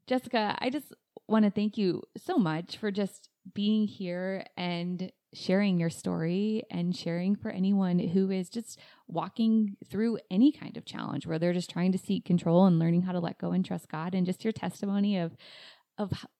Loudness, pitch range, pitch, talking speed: -30 LUFS, 175-210 Hz, 190 Hz, 190 wpm